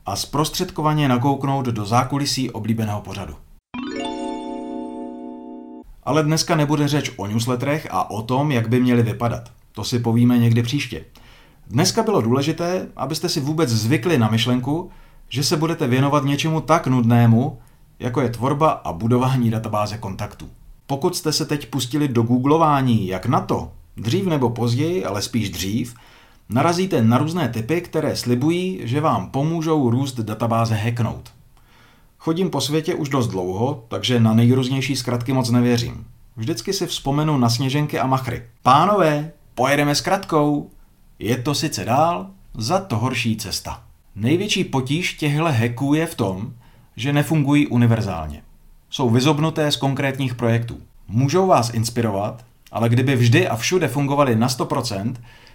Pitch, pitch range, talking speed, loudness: 125 Hz, 115-150 Hz, 145 wpm, -20 LUFS